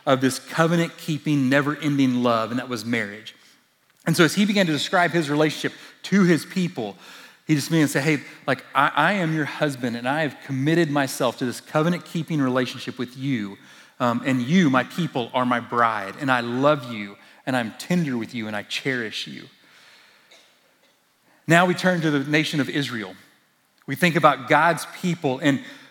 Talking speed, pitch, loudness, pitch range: 190 wpm, 145 Hz, -22 LUFS, 125-160 Hz